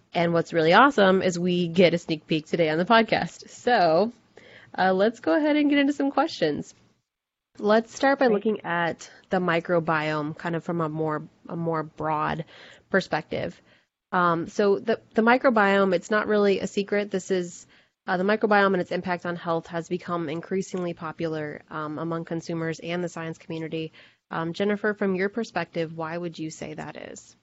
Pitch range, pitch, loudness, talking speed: 165-205 Hz, 175 Hz, -25 LUFS, 180 wpm